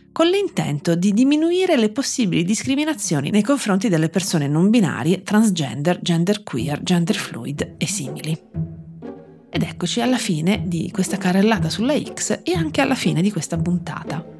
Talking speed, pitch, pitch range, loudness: 150 wpm, 190 Hz, 170-235 Hz, -20 LUFS